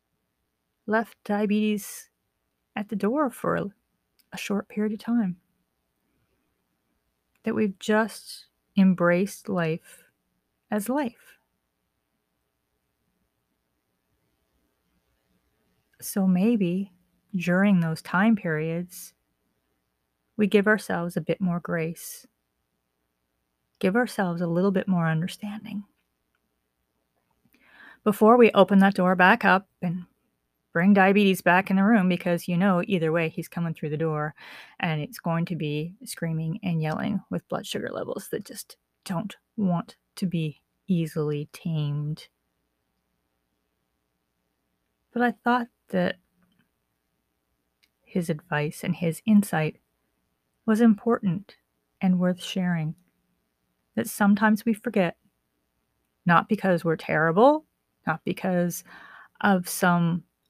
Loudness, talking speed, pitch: -25 LUFS, 105 wpm, 170 Hz